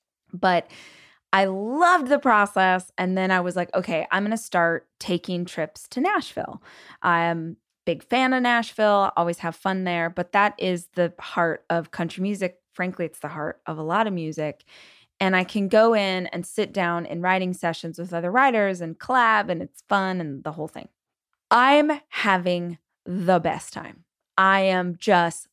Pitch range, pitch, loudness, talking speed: 170-205 Hz, 185 Hz, -23 LUFS, 185 wpm